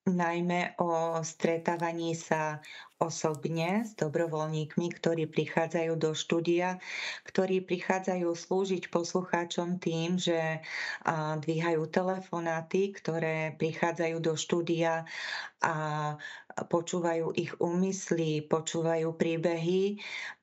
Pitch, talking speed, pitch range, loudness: 170 Hz, 85 wpm, 160-180 Hz, -31 LUFS